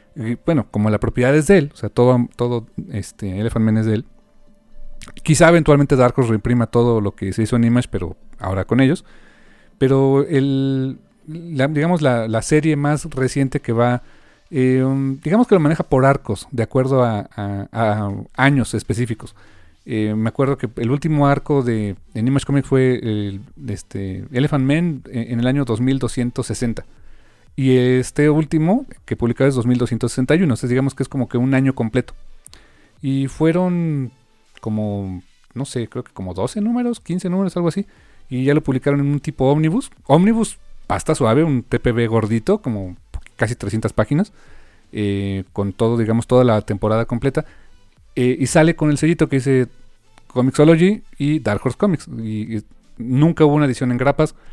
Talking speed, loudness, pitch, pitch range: 170 wpm, -18 LUFS, 125 Hz, 110-145 Hz